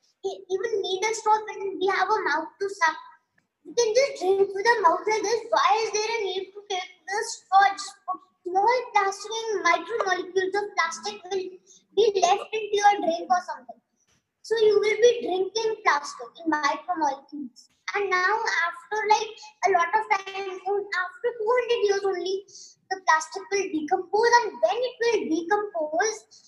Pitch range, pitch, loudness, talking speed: 360-430 Hz, 390 Hz, -25 LUFS, 165 wpm